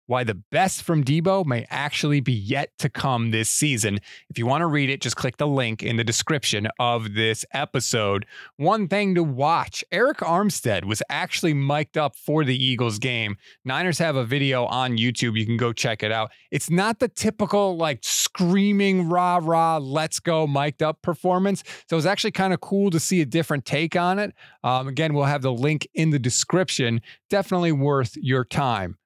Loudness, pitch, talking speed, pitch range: -23 LUFS, 145 Hz, 195 wpm, 125-170 Hz